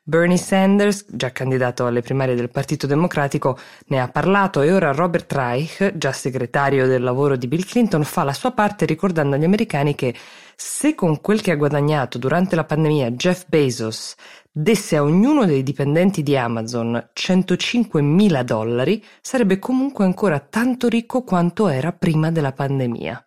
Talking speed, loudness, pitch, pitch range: 160 wpm, -19 LUFS, 155 Hz, 135-195 Hz